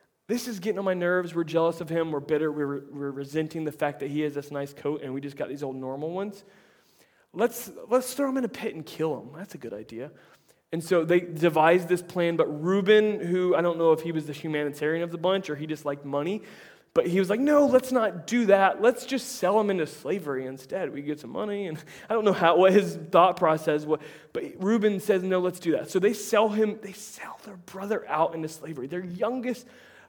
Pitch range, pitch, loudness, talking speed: 155-210 Hz, 175 Hz, -26 LUFS, 240 wpm